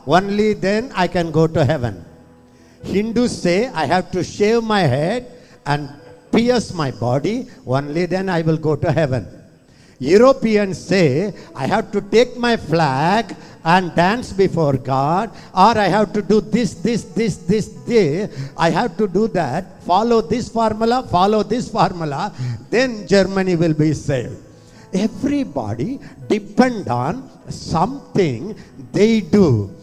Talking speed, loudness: 140 wpm, -18 LUFS